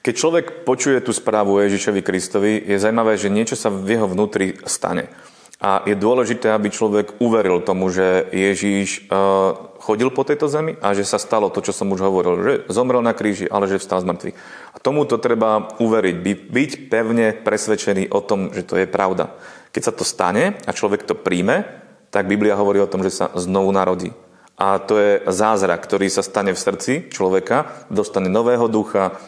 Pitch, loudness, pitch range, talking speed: 100 Hz, -19 LUFS, 95-110 Hz, 185 wpm